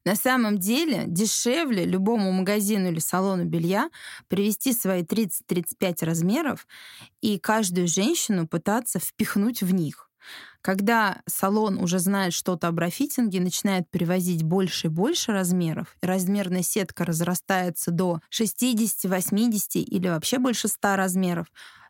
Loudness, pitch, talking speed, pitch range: -24 LUFS, 190 Hz, 120 wpm, 180-215 Hz